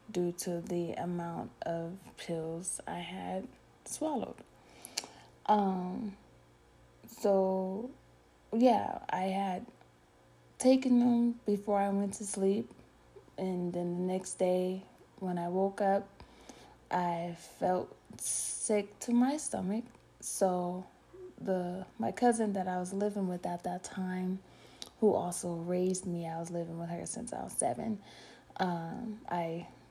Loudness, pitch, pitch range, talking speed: -34 LUFS, 185 Hz, 175-205 Hz, 125 wpm